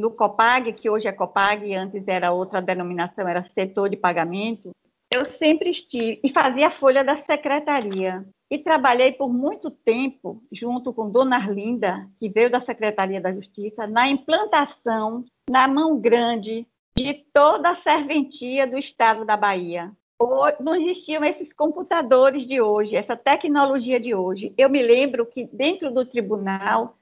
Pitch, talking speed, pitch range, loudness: 245 Hz, 155 wpm, 210-280 Hz, -21 LUFS